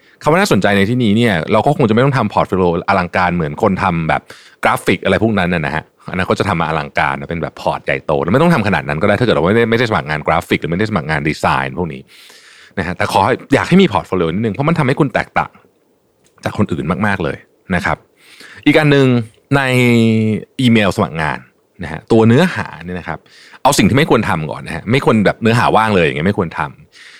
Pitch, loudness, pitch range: 105 Hz, -14 LUFS, 90-125 Hz